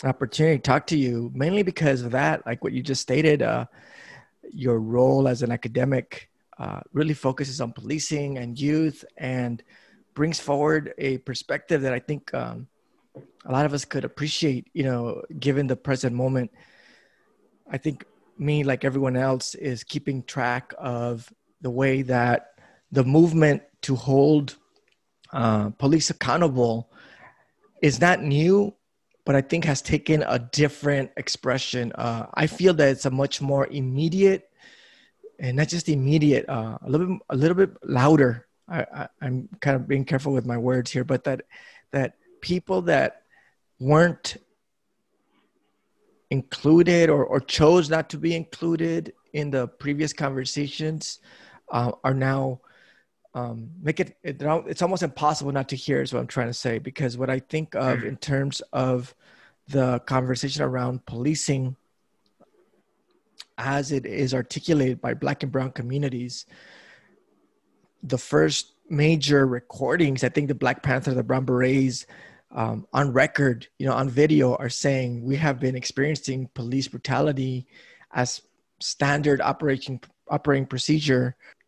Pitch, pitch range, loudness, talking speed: 135 Hz, 130-150 Hz, -24 LUFS, 150 wpm